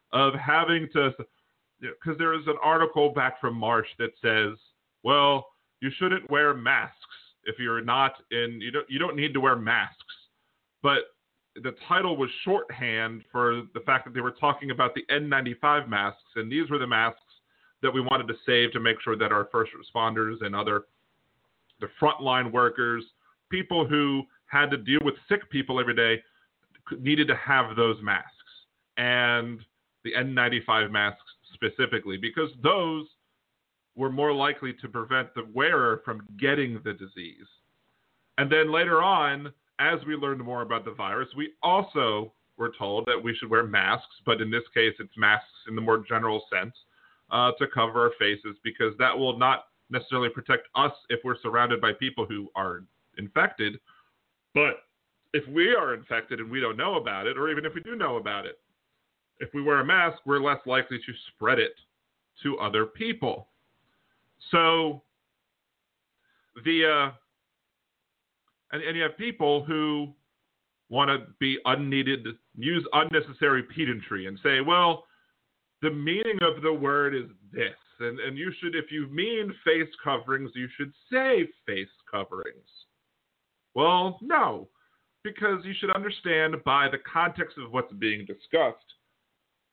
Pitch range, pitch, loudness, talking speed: 115-155 Hz, 135 Hz, -26 LUFS, 160 wpm